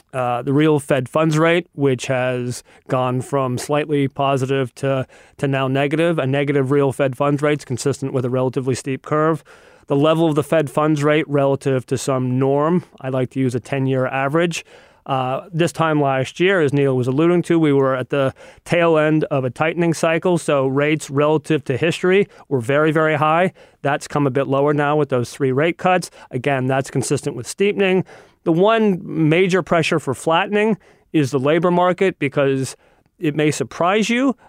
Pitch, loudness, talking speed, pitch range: 145 Hz, -18 LUFS, 190 wpm, 135-160 Hz